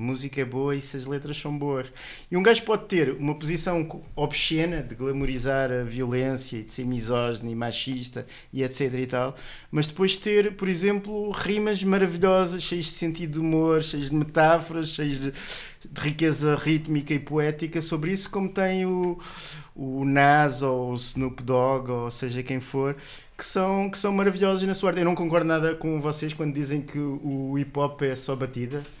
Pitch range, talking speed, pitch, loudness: 135-175 Hz, 190 wpm, 150 Hz, -26 LUFS